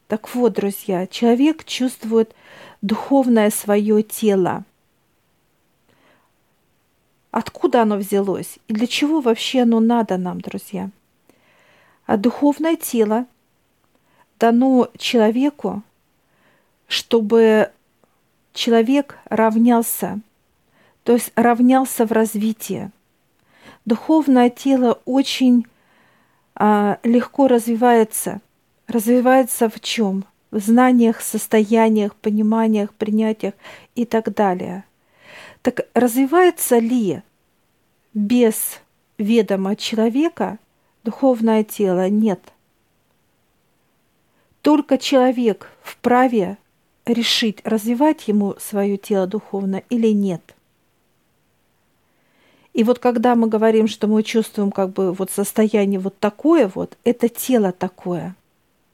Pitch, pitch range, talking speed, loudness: 225 Hz, 210-245 Hz, 90 wpm, -18 LUFS